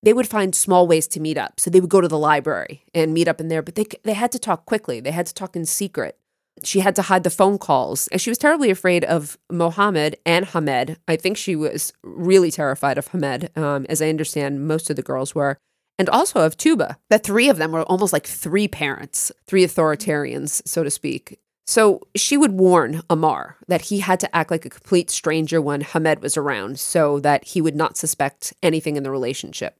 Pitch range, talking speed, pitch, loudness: 155-195 Hz, 225 wpm, 170 Hz, -20 LUFS